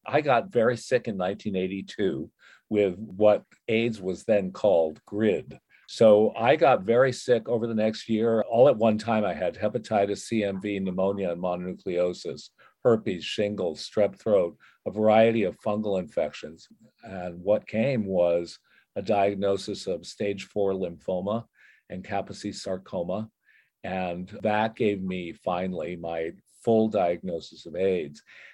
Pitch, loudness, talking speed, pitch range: 100 Hz, -26 LUFS, 135 wpm, 90-110 Hz